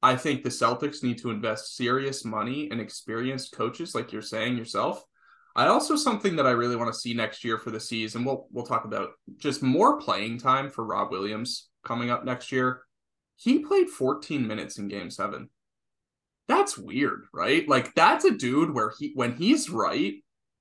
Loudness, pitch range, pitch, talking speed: -27 LUFS, 115-145 Hz, 125 Hz, 185 wpm